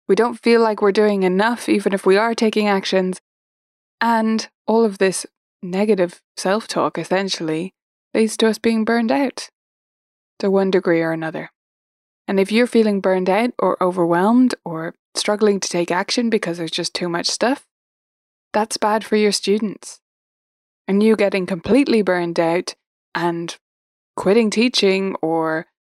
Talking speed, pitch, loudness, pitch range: 155 wpm, 200 Hz, -18 LUFS, 180-220 Hz